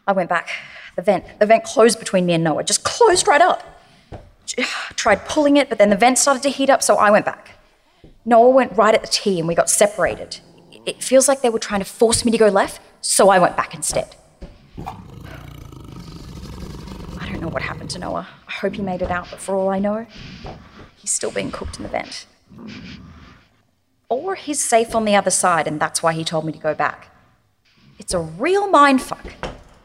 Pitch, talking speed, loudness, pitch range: 215 Hz, 210 wpm, -17 LUFS, 185-260 Hz